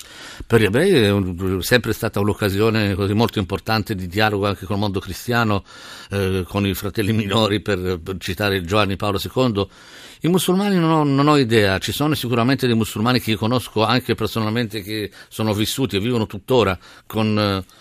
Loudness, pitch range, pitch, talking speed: -20 LUFS, 100-115 Hz, 110 Hz, 180 wpm